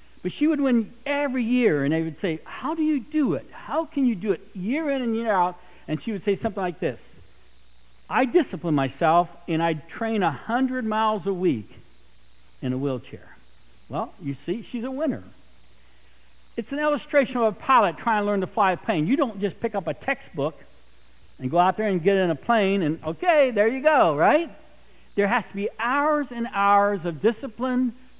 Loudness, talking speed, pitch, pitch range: -24 LUFS, 205 wpm, 205 Hz, 160-250 Hz